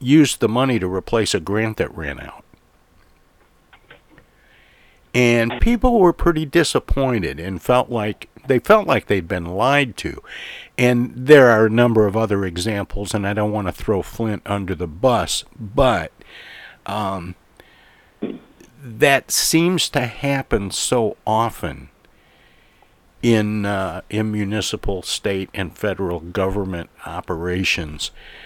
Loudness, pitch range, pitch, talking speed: -19 LUFS, 95-125 Hz, 105 Hz, 125 wpm